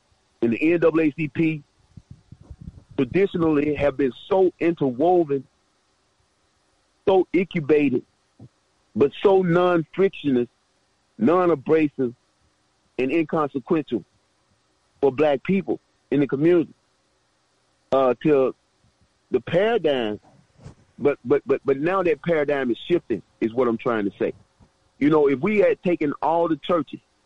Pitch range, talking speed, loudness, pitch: 130-170 Hz, 115 wpm, -22 LUFS, 150 Hz